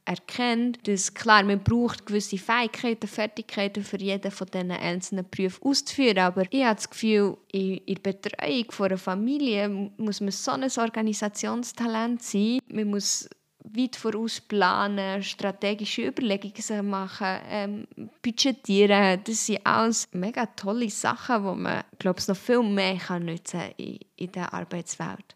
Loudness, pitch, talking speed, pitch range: -26 LUFS, 205 Hz, 145 wpm, 195-230 Hz